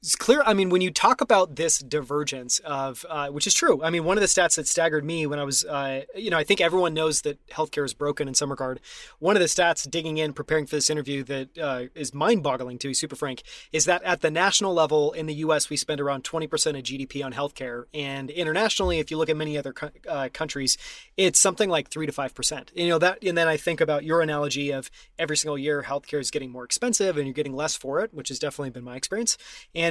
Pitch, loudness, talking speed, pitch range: 150 Hz, -24 LUFS, 250 wpm, 140-165 Hz